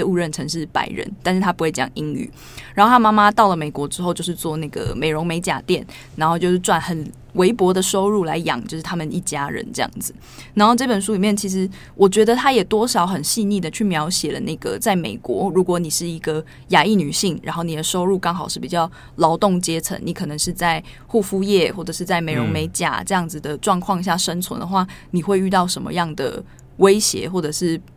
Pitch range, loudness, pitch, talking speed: 160-195 Hz, -19 LUFS, 180 Hz, 325 characters per minute